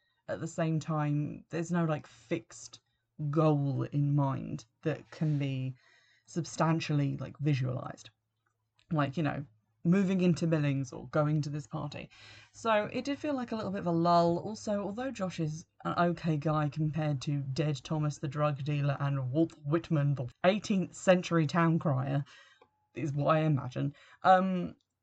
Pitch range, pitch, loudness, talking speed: 140-170 Hz, 155 Hz, -32 LUFS, 160 wpm